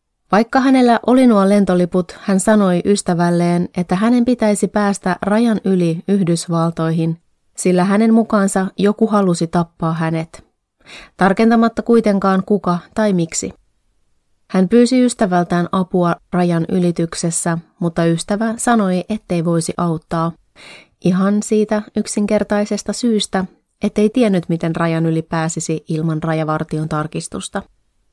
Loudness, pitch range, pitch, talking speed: -16 LUFS, 170-210 Hz, 185 Hz, 110 wpm